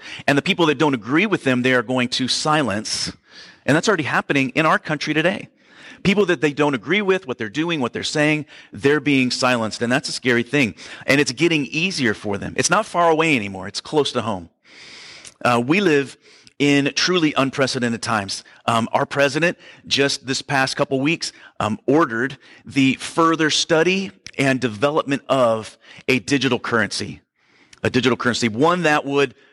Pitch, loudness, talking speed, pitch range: 140 Hz, -19 LUFS, 180 wpm, 125-155 Hz